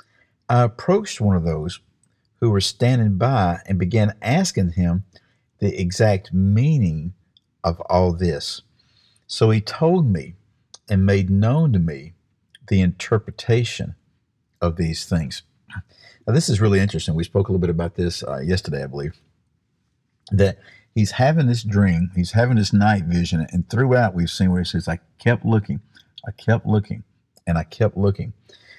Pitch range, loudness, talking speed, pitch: 90-115 Hz, -20 LUFS, 160 wpm, 100 Hz